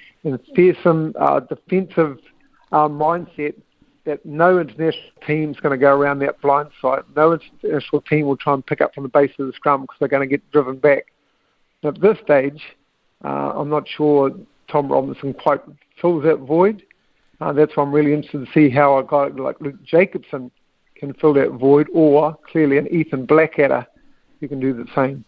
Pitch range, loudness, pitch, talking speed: 140-155 Hz, -18 LUFS, 150 Hz, 195 wpm